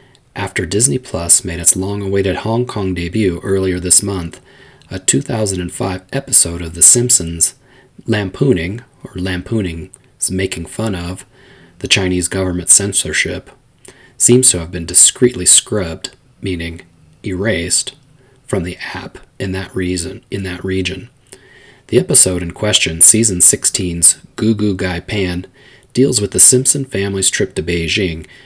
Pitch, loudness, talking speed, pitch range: 95 Hz, -13 LUFS, 135 wpm, 90-115 Hz